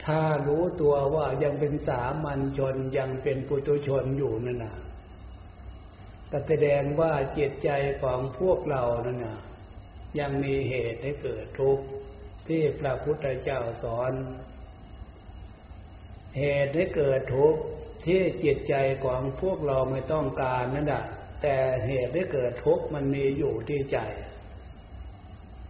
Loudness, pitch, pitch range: -28 LUFS, 130 Hz, 100-145 Hz